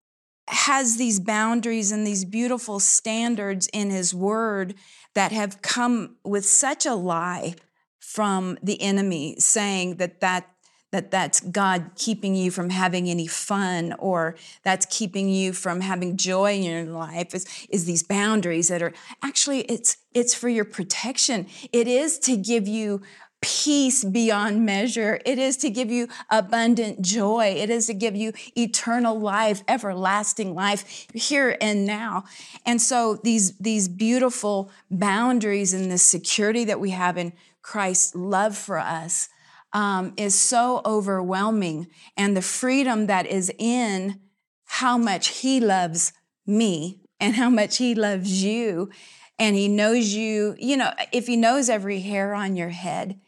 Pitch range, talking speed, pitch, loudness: 190-230 Hz, 150 wpm, 205 Hz, -22 LUFS